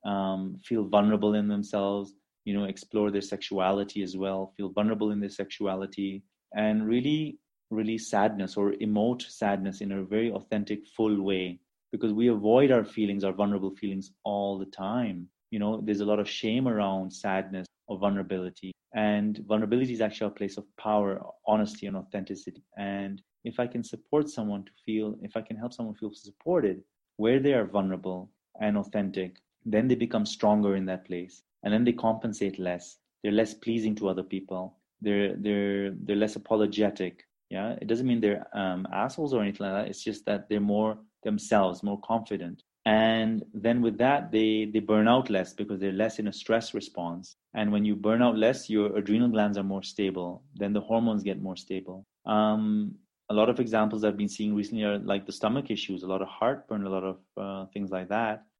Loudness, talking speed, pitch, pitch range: -29 LUFS, 190 wpm, 105 Hz, 95-110 Hz